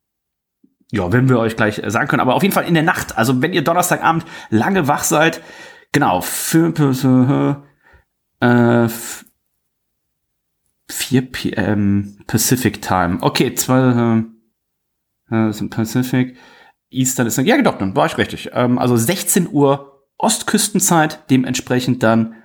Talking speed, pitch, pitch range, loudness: 135 wpm, 125 Hz, 115-155 Hz, -16 LUFS